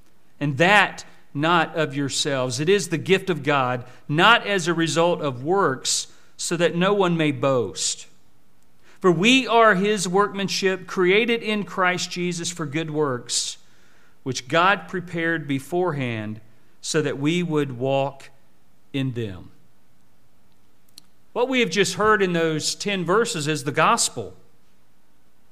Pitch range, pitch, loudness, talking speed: 130-185 Hz, 160 Hz, -21 LUFS, 135 wpm